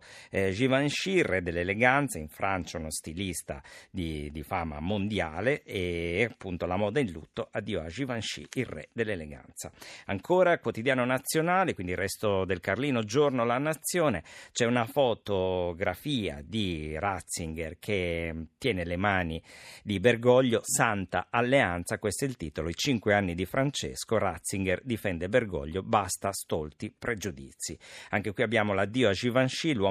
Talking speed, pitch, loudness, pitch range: 140 wpm, 100 Hz, -29 LUFS, 85-125 Hz